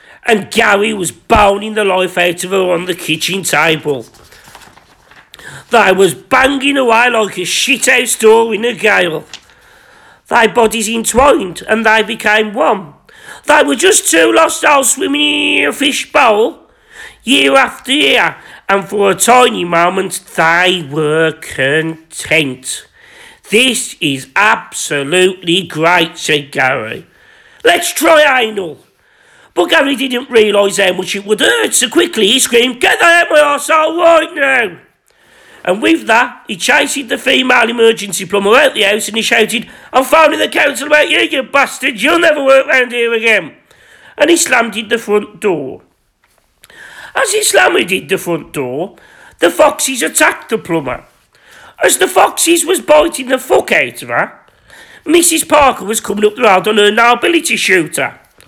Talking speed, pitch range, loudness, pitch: 160 wpm, 195-290 Hz, -11 LUFS, 230 Hz